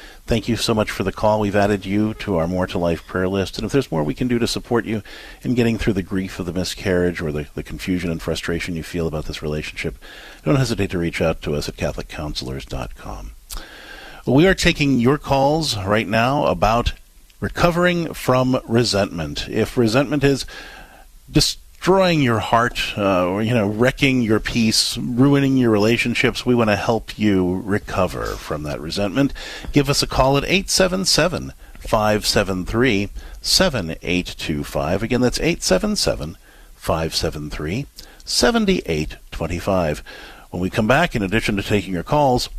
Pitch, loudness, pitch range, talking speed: 105 Hz, -19 LUFS, 90-125 Hz, 155 wpm